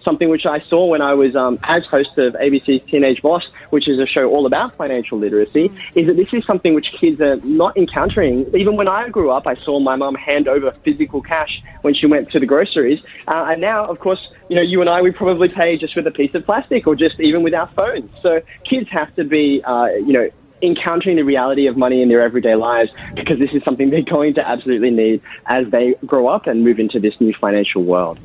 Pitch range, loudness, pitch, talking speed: 125-175 Hz, -16 LUFS, 145 Hz, 240 wpm